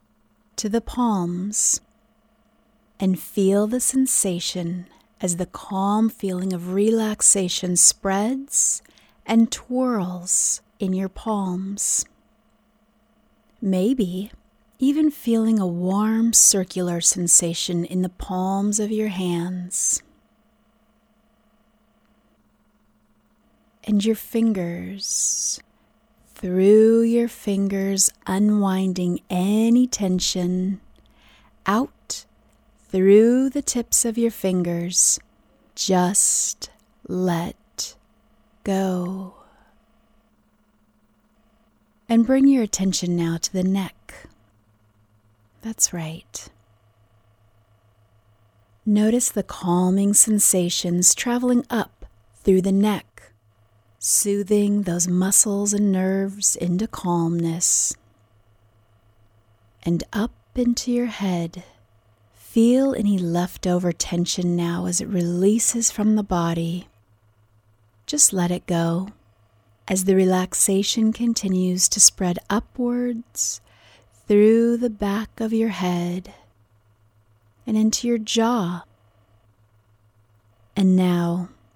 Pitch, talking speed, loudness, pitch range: 190 Hz, 85 wpm, -20 LUFS, 170-220 Hz